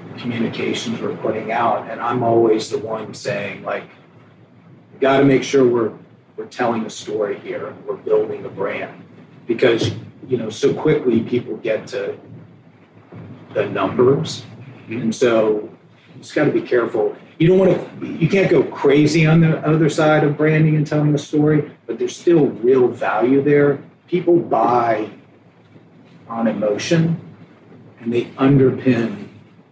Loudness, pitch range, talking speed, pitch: -18 LUFS, 125-180 Hz, 150 wpm, 150 Hz